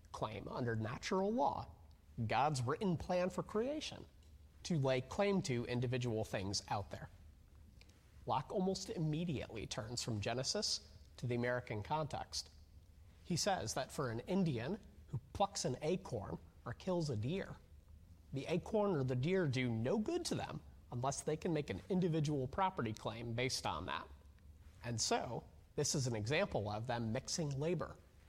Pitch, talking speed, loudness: 125 Hz, 155 wpm, -40 LUFS